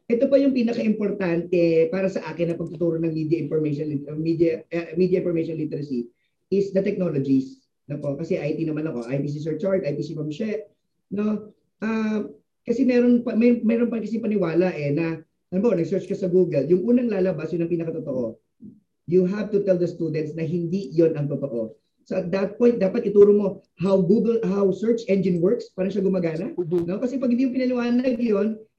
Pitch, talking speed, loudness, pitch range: 185 Hz, 180 wpm, -23 LUFS, 160-210 Hz